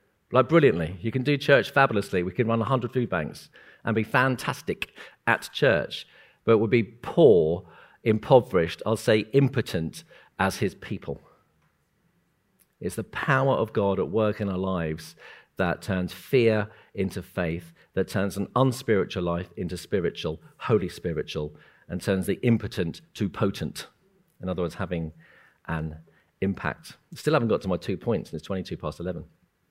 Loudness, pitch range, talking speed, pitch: -26 LUFS, 90-120 Hz, 155 wpm, 100 Hz